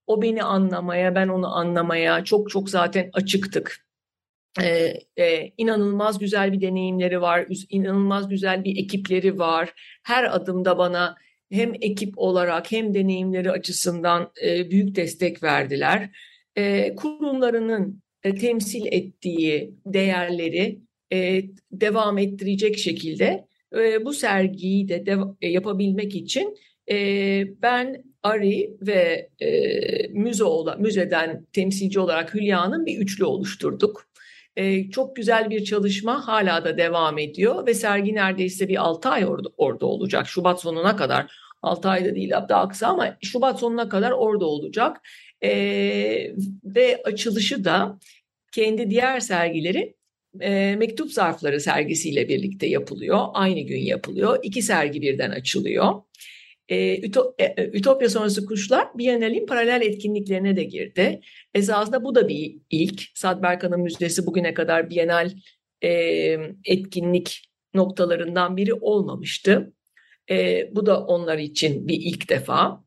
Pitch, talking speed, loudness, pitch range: 195 Hz, 120 wpm, -22 LUFS, 175-220 Hz